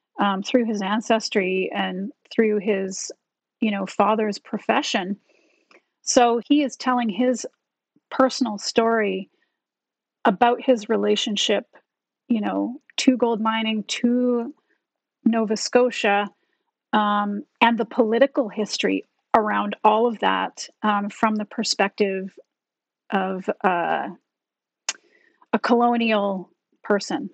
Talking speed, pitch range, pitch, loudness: 105 wpm, 205-250 Hz, 225 Hz, -22 LUFS